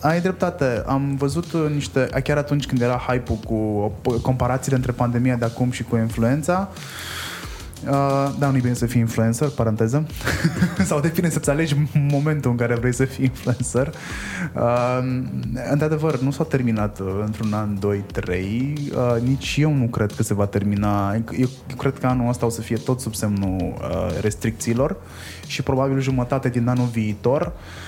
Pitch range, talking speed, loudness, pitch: 110-140 Hz, 155 wpm, -22 LUFS, 125 Hz